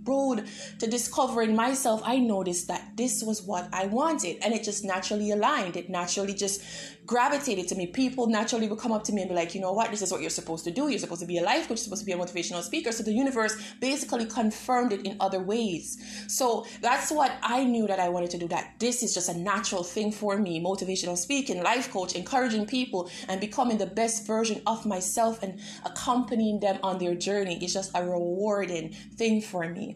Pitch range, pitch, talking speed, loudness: 185-230 Hz, 210 Hz, 220 wpm, -28 LUFS